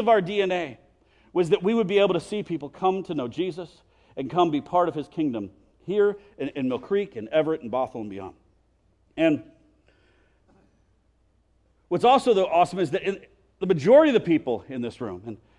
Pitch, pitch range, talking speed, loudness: 180 Hz, 155-205 Hz, 195 wpm, -24 LUFS